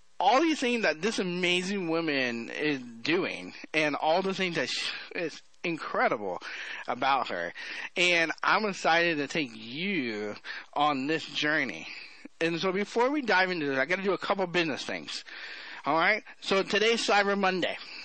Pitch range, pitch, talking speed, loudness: 150-200 Hz, 180 Hz, 160 wpm, -28 LUFS